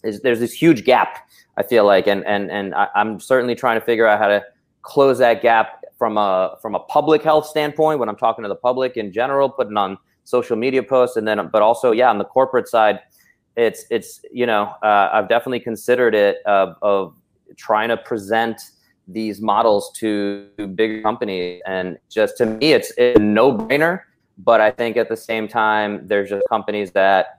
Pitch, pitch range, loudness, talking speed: 115 Hz, 105-130 Hz, -18 LUFS, 200 wpm